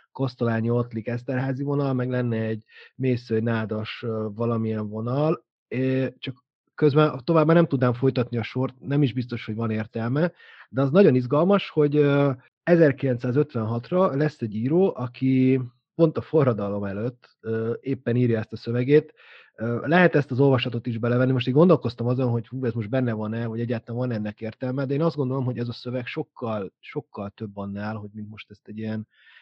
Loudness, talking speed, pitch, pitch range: -24 LUFS, 180 wpm, 125 Hz, 115-140 Hz